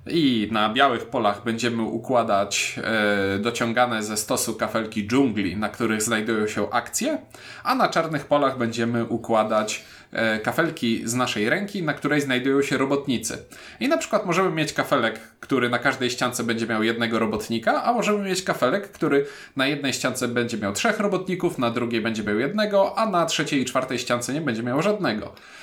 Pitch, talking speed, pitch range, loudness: 120 Hz, 175 wpm, 110-150 Hz, -23 LUFS